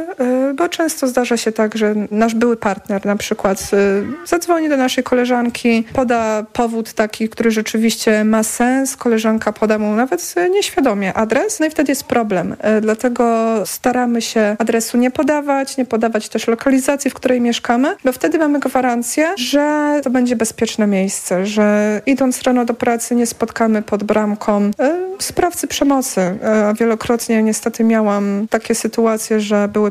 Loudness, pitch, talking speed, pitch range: -16 LUFS, 230 Hz, 150 wpm, 215-265 Hz